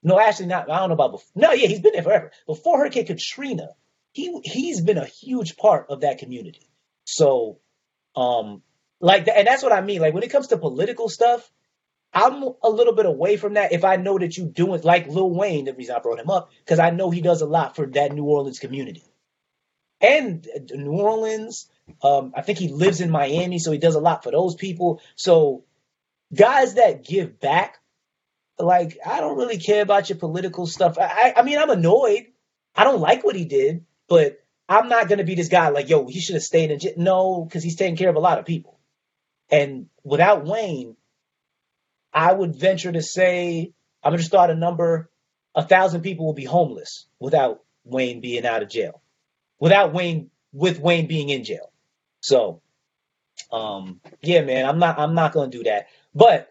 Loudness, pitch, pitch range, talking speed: -20 LUFS, 180 Hz, 155-210 Hz, 205 wpm